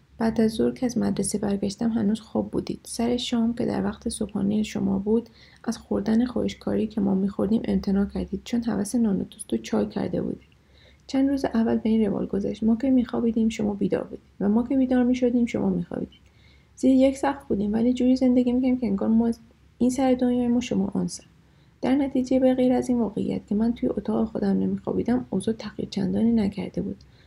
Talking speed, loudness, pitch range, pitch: 195 wpm, -25 LUFS, 205-245 Hz, 225 Hz